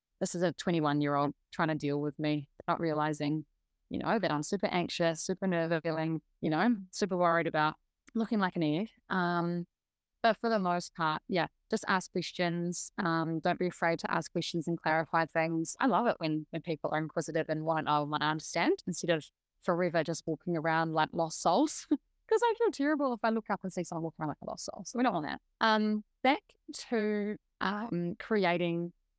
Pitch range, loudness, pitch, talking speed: 160-200 Hz, -32 LUFS, 170 Hz, 210 wpm